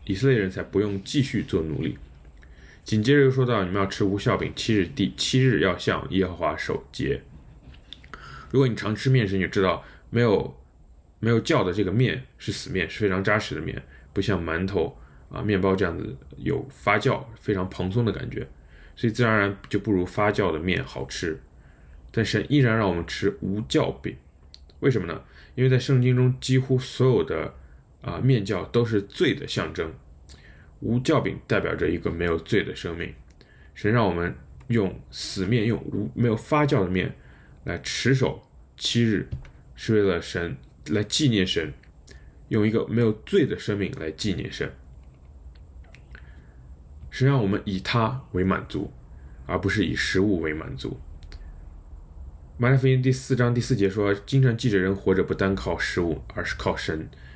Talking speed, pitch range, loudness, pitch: 250 characters per minute, 75-120 Hz, -25 LUFS, 95 Hz